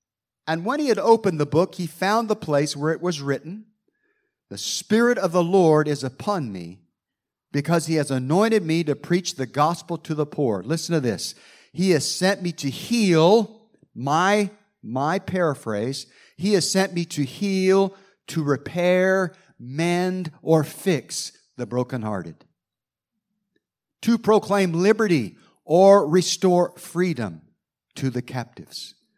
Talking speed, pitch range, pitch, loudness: 140 wpm, 145-195 Hz, 175 Hz, -22 LUFS